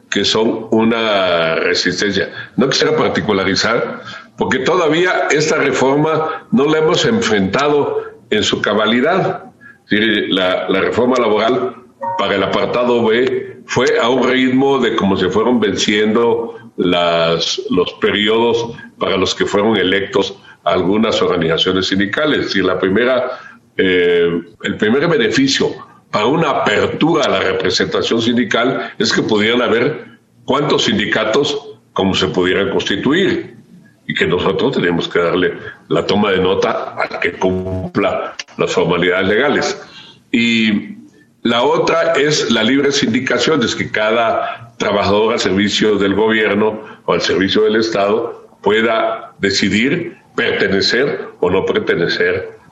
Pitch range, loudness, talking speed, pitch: 100-145 Hz, -15 LUFS, 125 wpm, 115 Hz